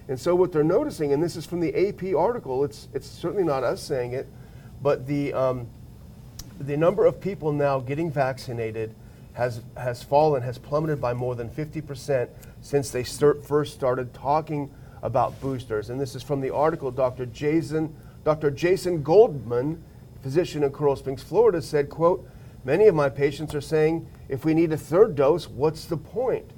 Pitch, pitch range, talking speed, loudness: 140 Hz, 125-155 Hz, 180 wpm, -25 LUFS